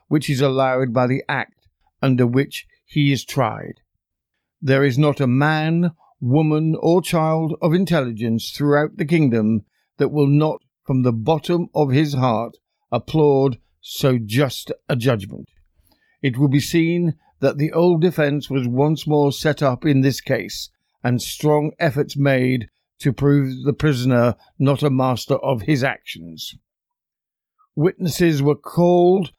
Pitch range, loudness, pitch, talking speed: 130-155 Hz, -19 LUFS, 145 Hz, 145 wpm